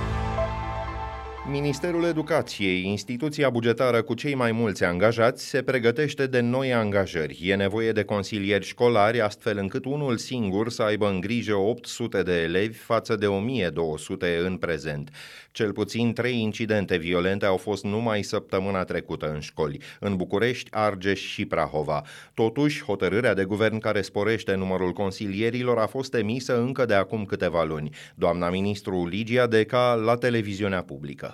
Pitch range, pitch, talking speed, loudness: 95-120 Hz, 110 Hz, 145 wpm, -25 LUFS